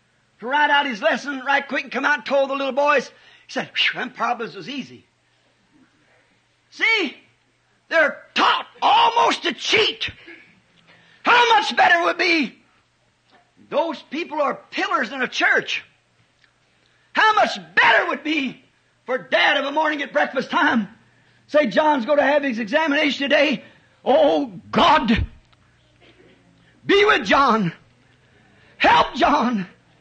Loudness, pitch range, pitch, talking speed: -19 LUFS, 245-310 Hz, 285 Hz, 135 wpm